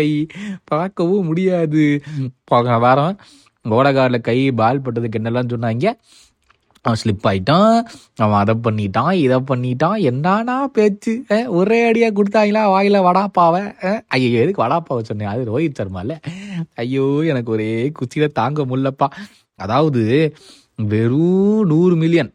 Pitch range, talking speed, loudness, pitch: 120-185 Hz, 90 wpm, -17 LUFS, 150 Hz